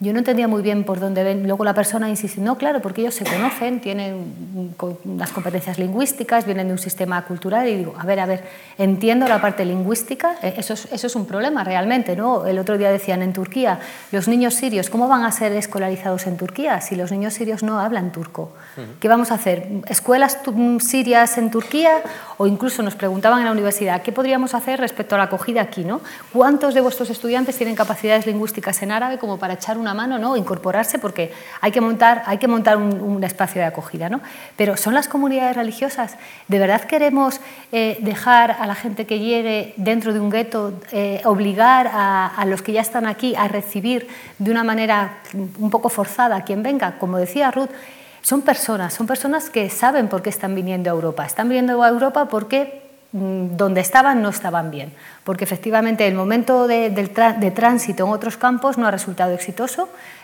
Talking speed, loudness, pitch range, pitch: 200 wpm, -19 LUFS, 195-245 Hz, 220 Hz